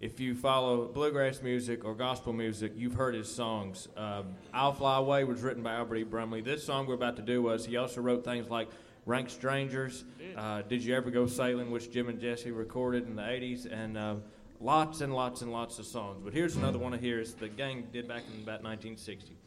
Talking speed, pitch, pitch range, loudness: 225 wpm, 120 Hz, 110-125 Hz, -34 LUFS